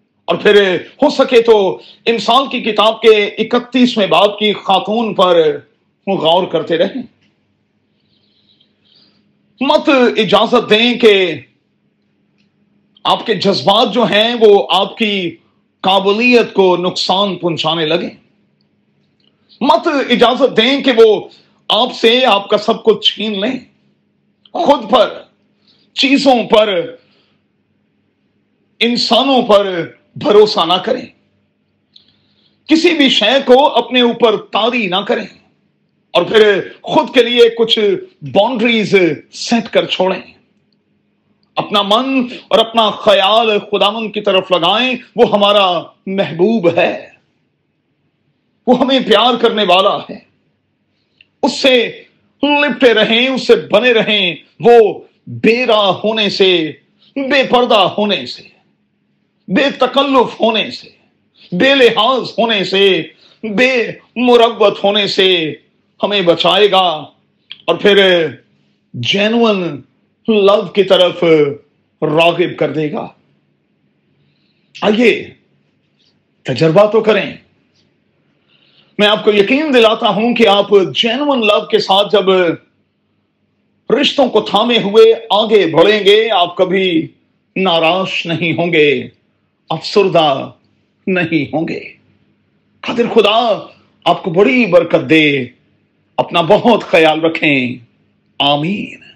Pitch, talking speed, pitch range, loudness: 210 Hz, 110 wpm, 185-240 Hz, -12 LUFS